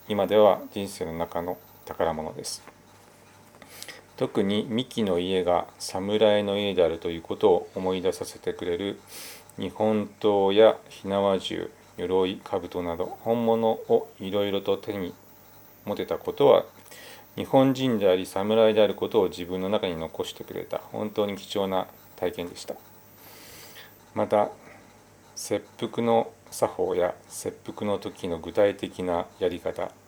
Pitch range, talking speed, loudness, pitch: 95-115 Hz, 245 characters per minute, -26 LUFS, 100 Hz